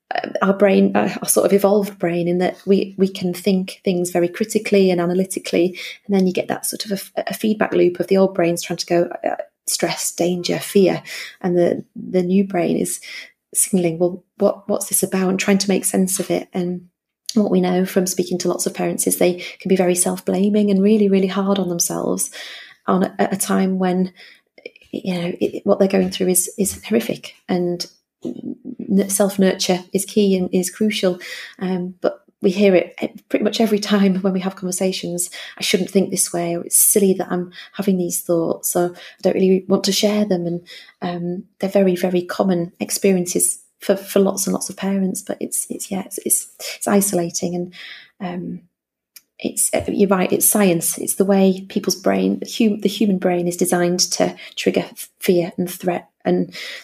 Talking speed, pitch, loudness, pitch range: 200 wpm, 190 Hz, -19 LUFS, 180-200 Hz